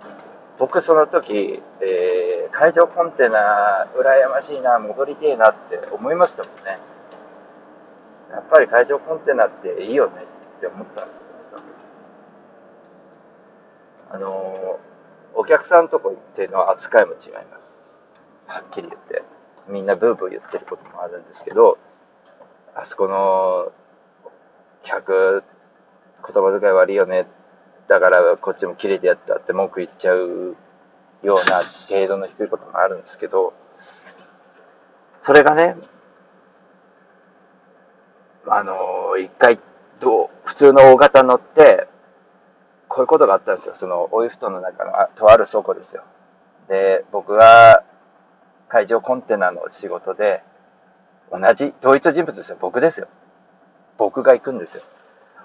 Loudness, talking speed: -16 LUFS, 260 characters per minute